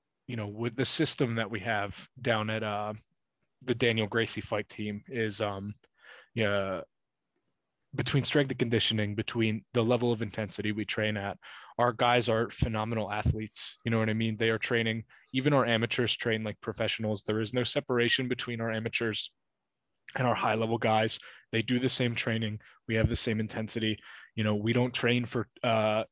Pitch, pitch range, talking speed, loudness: 115 Hz, 110-120 Hz, 180 wpm, -30 LUFS